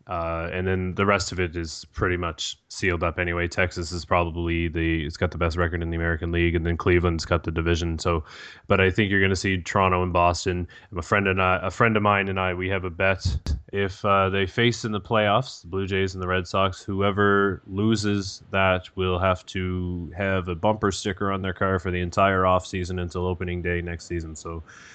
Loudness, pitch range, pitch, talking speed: -24 LUFS, 85-95 Hz, 90 Hz, 230 wpm